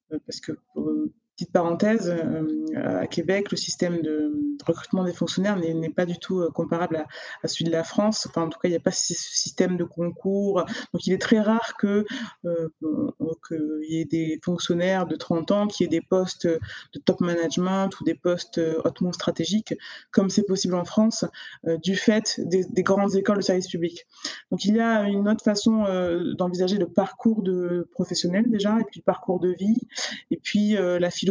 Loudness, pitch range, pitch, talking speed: -25 LUFS, 170-205 Hz, 180 Hz, 195 wpm